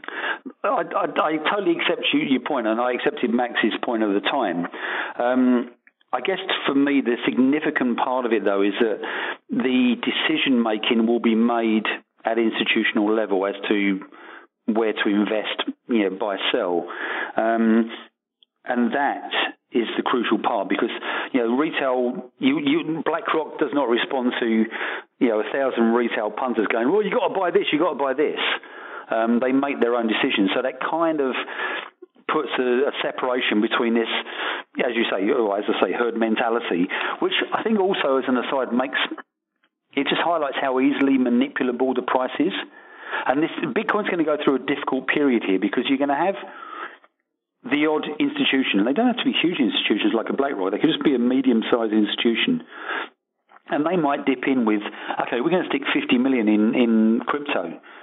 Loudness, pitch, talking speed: -22 LUFS, 130 Hz, 185 wpm